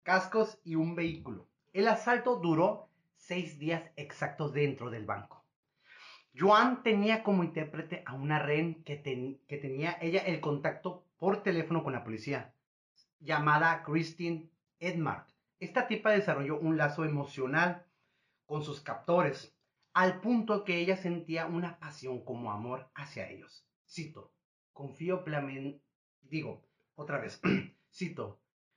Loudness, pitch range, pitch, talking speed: -33 LUFS, 140-180 Hz, 165 Hz, 125 wpm